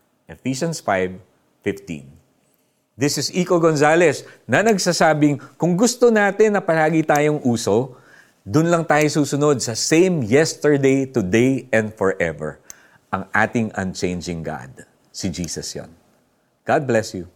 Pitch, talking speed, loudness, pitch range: 135 Hz, 120 wpm, -19 LUFS, 100-160 Hz